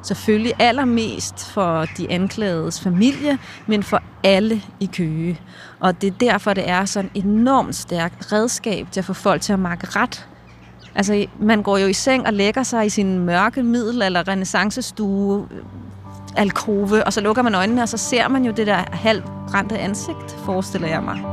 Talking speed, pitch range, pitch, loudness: 175 wpm, 185-225 Hz, 200 Hz, -19 LUFS